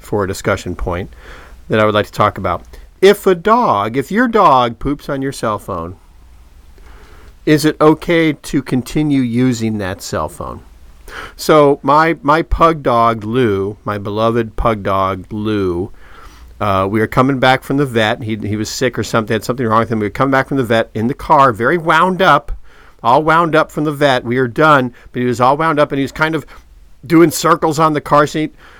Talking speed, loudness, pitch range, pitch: 210 wpm, -14 LUFS, 105-150 Hz, 125 Hz